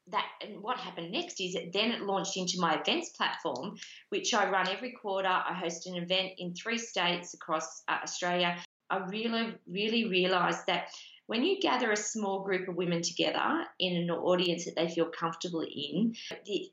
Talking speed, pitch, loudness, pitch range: 185 wpm, 185 Hz, -32 LUFS, 175-215 Hz